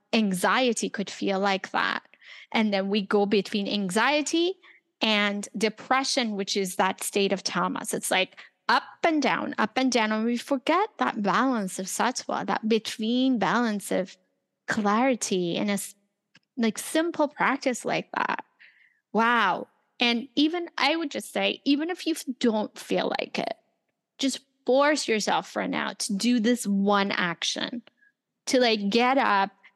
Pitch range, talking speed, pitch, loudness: 205-270 Hz, 150 wpm, 235 Hz, -26 LUFS